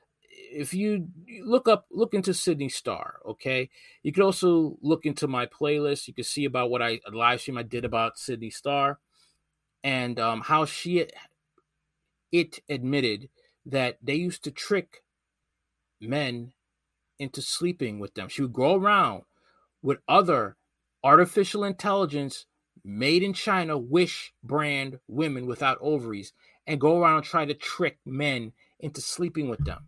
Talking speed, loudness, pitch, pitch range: 150 wpm, -26 LUFS, 145 Hz, 125-175 Hz